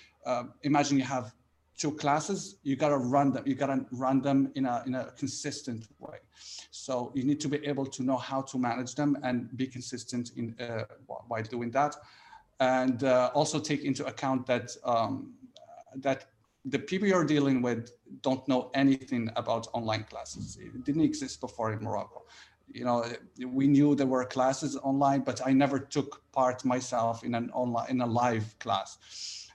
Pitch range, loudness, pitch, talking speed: 120-140 Hz, -30 LUFS, 130 Hz, 175 wpm